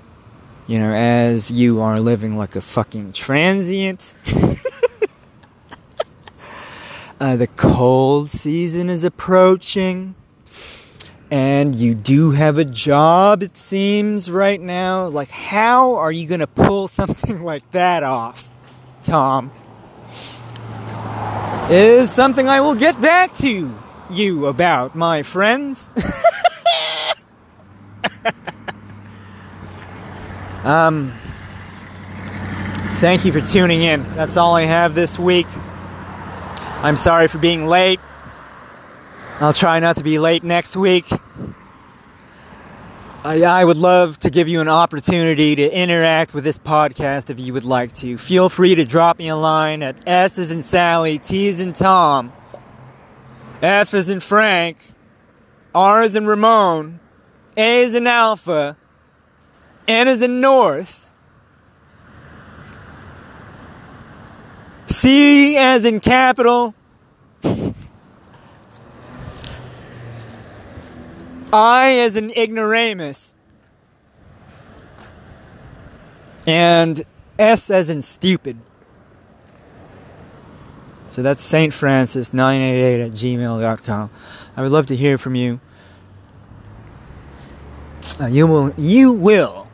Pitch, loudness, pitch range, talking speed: 155 Hz, -15 LUFS, 115-185 Hz, 105 wpm